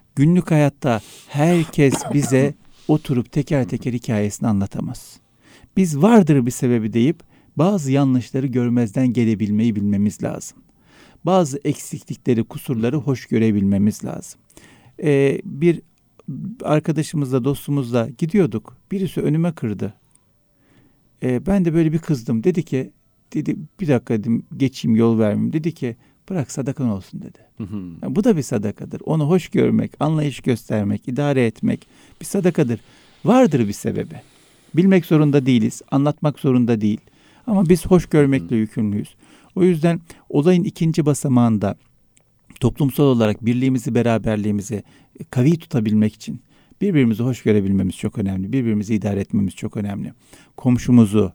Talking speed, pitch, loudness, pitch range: 125 wpm, 130 Hz, -19 LUFS, 115-155 Hz